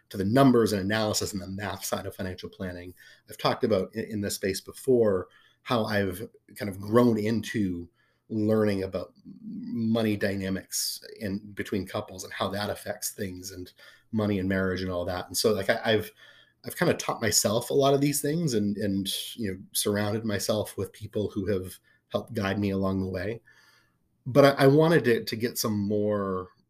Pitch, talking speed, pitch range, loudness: 105 Hz, 195 wpm, 95-115 Hz, -27 LUFS